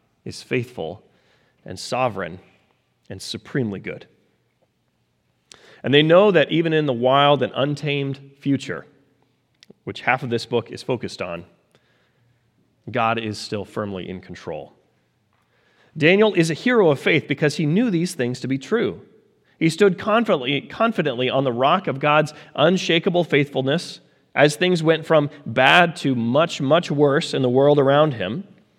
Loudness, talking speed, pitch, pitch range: -20 LUFS, 150 wpm, 140 Hz, 125-165 Hz